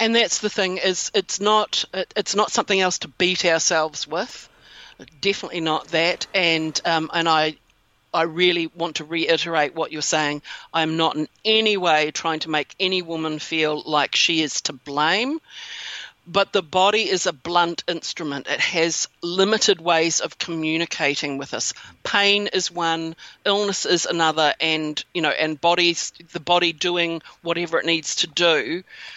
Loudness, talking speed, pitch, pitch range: -21 LUFS, 165 wpm, 170 Hz, 160-190 Hz